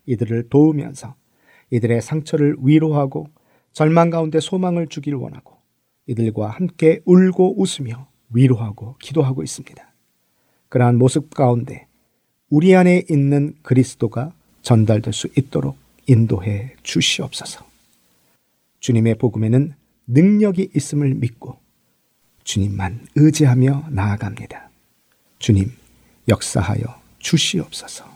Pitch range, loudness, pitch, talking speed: 115-155 Hz, -18 LUFS, 130 Hz, 265 characters per minute